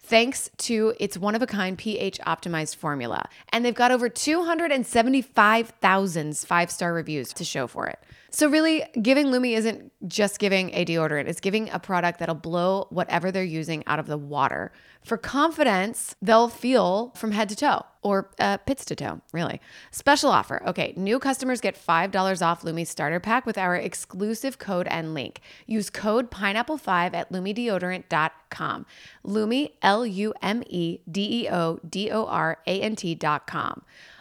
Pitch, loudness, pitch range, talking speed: 200 Hz, -25 LUFS, 175-235 Hz, 165 wpm